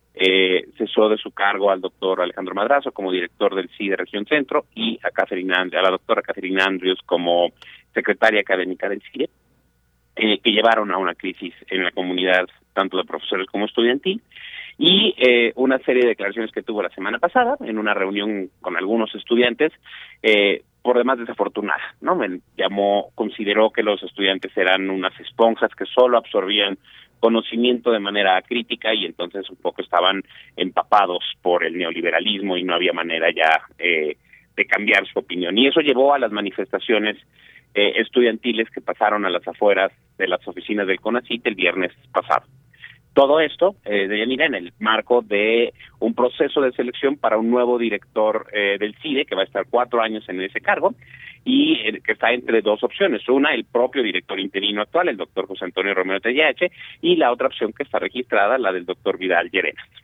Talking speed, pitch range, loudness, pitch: 180 wpm, 95-120 Hz, -20 LUFS, 105 Hz